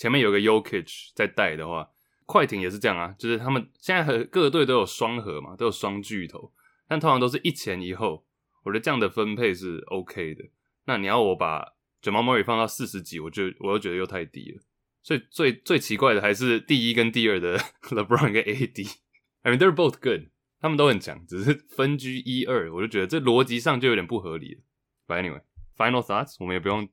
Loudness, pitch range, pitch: -25 LUFS, 95-130 Hz, 115 Hz